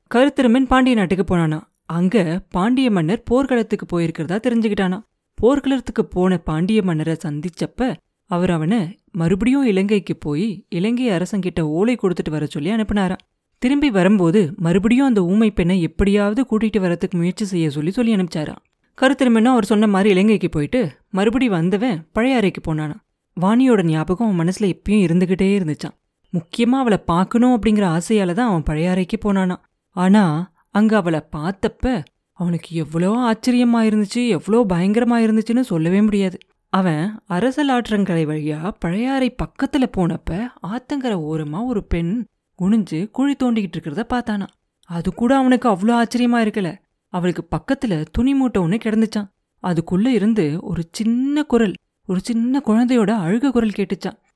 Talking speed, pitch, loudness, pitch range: 130 wpm, 205 Hz, -19 LUFS, 175-235 Hz